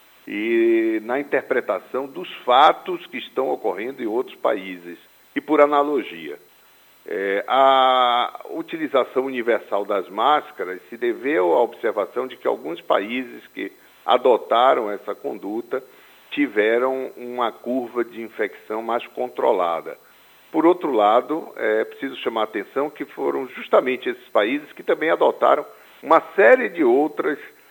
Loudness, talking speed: -21 LUFS, 130 wpm